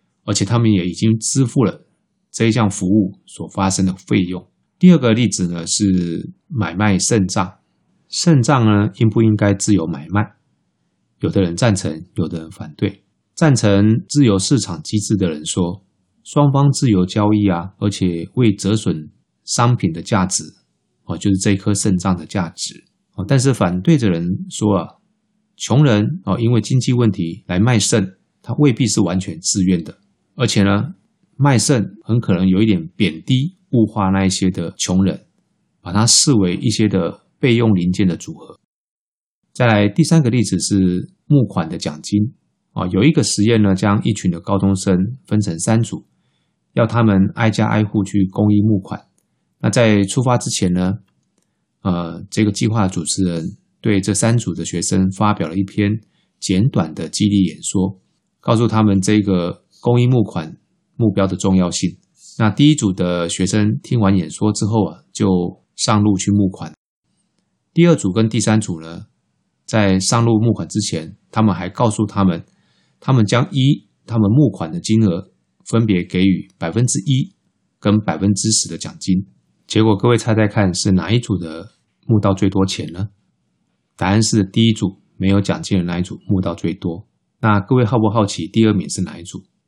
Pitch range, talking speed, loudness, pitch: 95-115 Hz, 245 characters per minute, -17 LUFS, 105 Hz